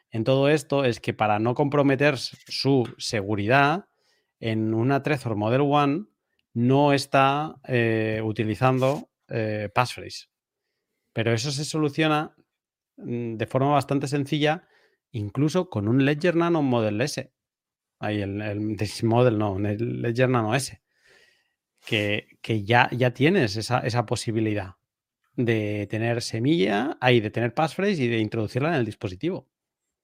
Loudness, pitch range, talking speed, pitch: -24 LUFS, 110-140 Hz, 135 wpm, 120 Hz